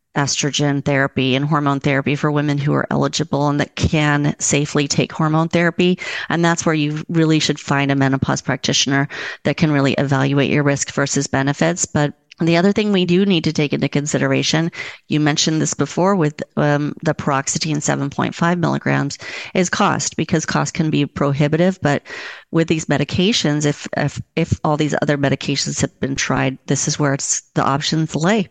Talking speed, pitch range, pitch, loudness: 175 wpm, 140-165 Hz, 150 Hz, -18 LUFS